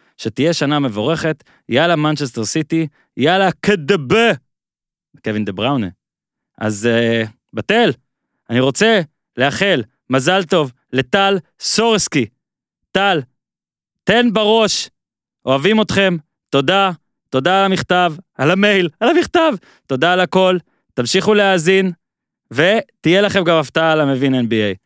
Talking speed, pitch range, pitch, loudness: 110 wpm, 135-195 Hz, 170 Hz, -15 LUFS